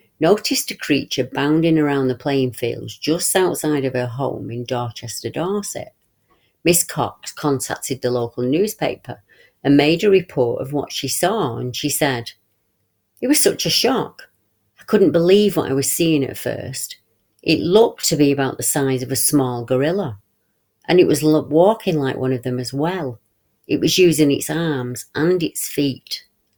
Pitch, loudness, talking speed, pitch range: 140 Hz, -19 LUFS, 170 wpm, 125-160 Hz